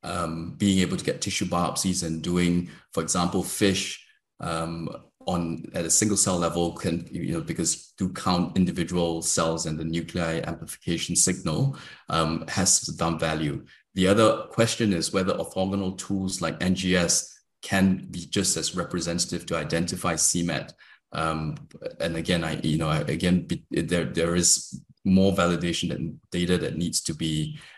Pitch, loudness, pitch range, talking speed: 85 Hz, -25 LUFS, 80-95 Hz, 155 wpm